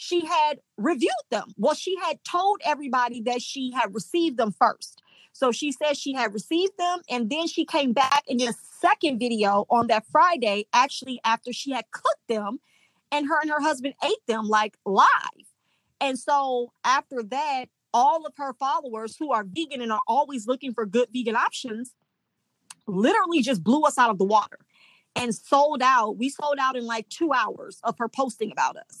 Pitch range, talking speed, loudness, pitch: 235-300 Hz, 190 wpm, -24 LUFS, 260 Hz